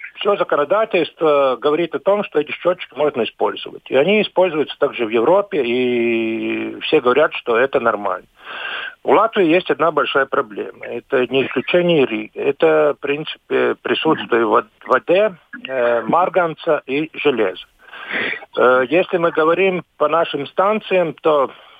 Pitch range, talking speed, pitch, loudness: 135-180 Hz, 130 wpm, 155 Hz, -17 LUFS